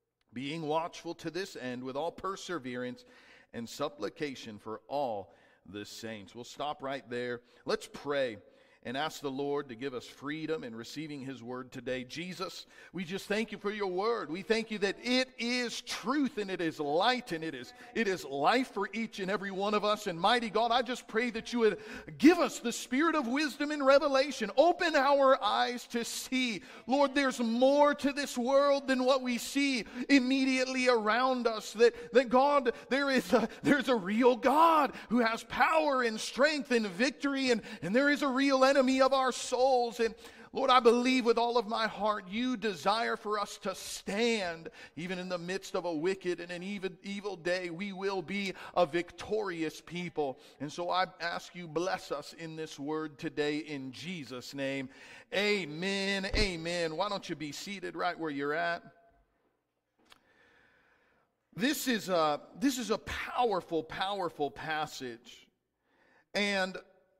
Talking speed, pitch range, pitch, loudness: 175 wpm, 165-250 Hz, 210 Hz, -31 LUFS